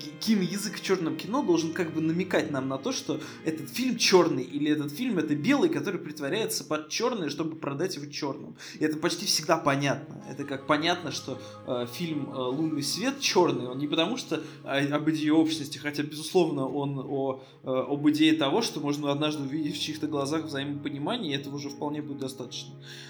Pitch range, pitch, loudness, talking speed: 140-165 Hz, 150 Hz, -28 LUFS, 185 wpm